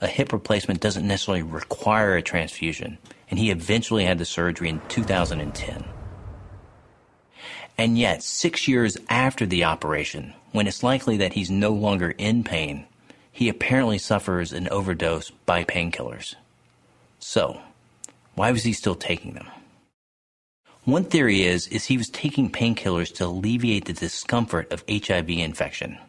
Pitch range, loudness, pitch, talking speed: 85-115 Hz, -24 LUFS, 100 Hz, 140 wpm